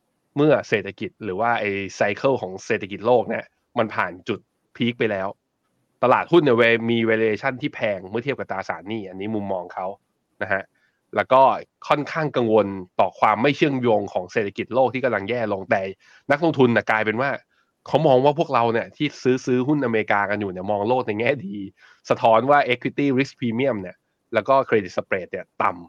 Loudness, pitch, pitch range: -22 LUFS, 115 Hz, 105-135 Hz